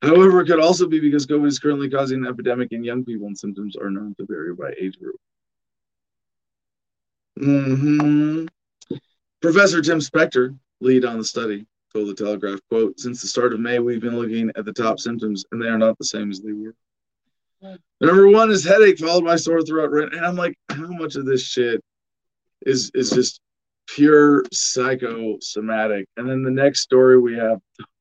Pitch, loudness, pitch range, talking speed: 125 Hz, -18 LUFS, 110-150 Hz, 180 wpm